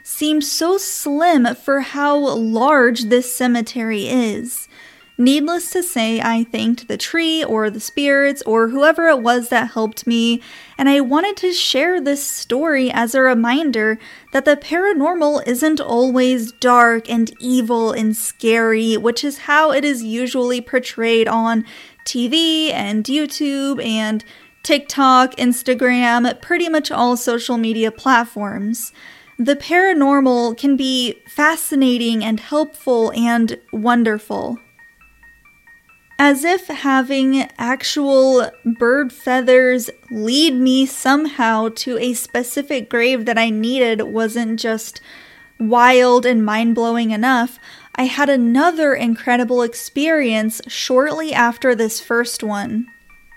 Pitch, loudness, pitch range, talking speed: 250 Hz, -16 LUFS, 230-285 Hz, 120 wpm